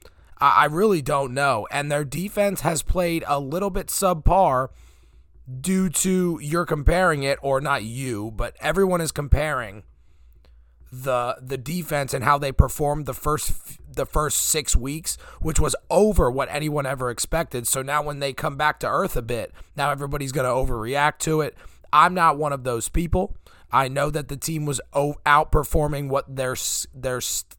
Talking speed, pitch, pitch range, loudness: 170 wpm, 145 Hz, 130-155 Hz, -23 LUFS